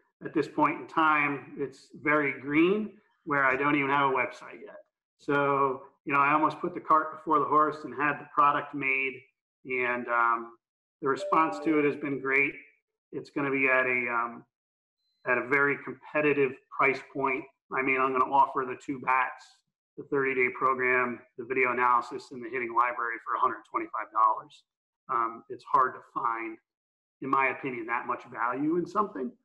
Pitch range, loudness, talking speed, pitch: 130-155 Hz, -28 LUFS, 185 wpm, 140 Hz